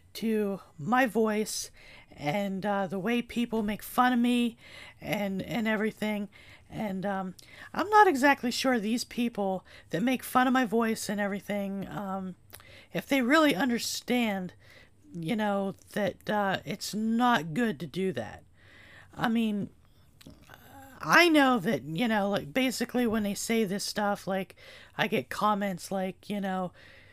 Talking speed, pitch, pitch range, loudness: 150 wpm, 205 Hz, 190-235 Hz, -29 LUFS